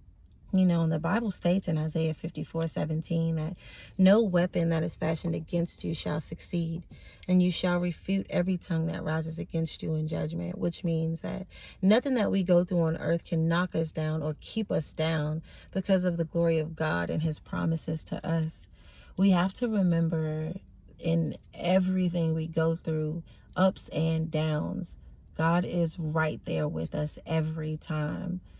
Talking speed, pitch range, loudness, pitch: 170 wpm, 155-175 Hz, -29 LUFS, 165 Hz